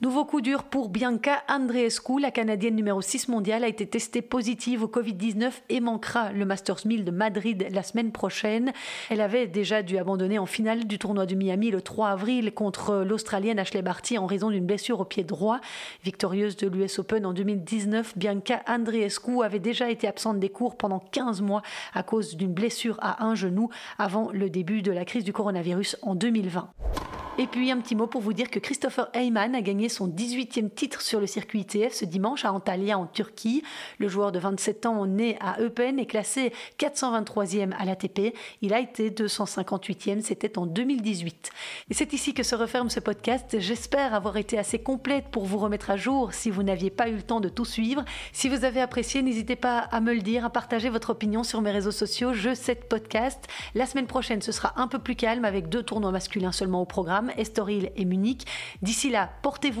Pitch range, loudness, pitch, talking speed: 200-240 Hz, -28 LUFS, 220 Hz, 205 wpm